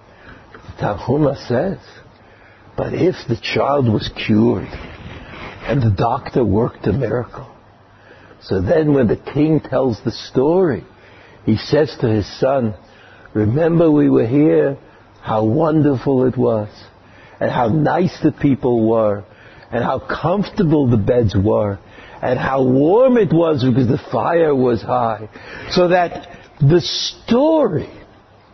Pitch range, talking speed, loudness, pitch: 110-150 Hz, 130 wpm, -17 LUFS, 125 Hz